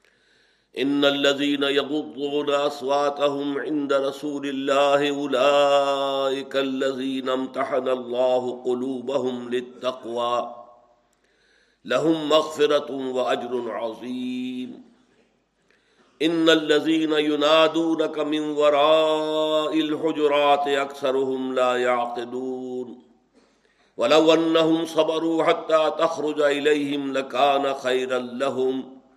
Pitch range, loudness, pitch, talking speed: 130-150 Hz, -22 LUFS, 140 Hz, 70 wpm